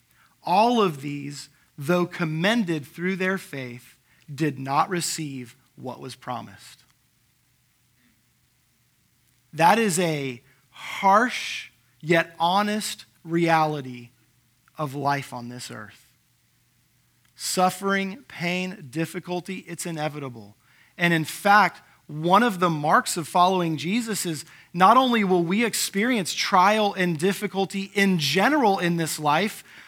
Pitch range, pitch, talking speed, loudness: 130-190 Hz, 165 Hz, 110 wpm, -23 LUFS